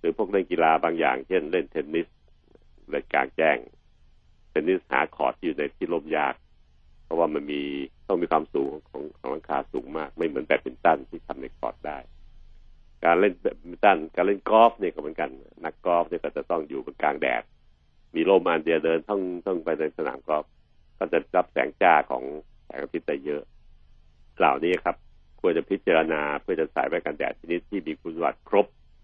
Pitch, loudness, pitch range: 75 Hz, -26 LUFS, 70-85 Hz